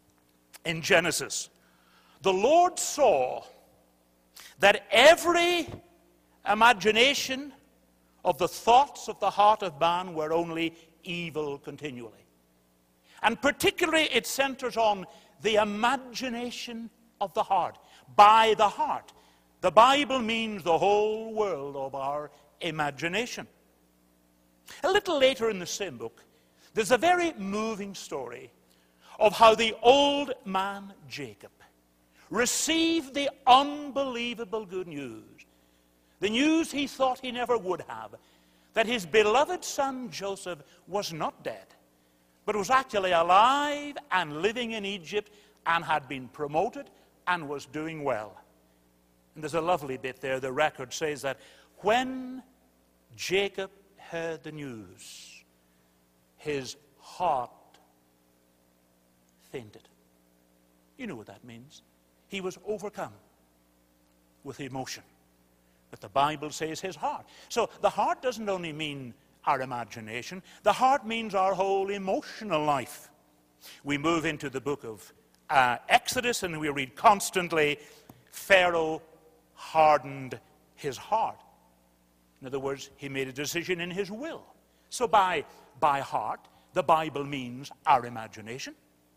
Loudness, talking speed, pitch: -27 LUFS, 120 wpm, 165 Hz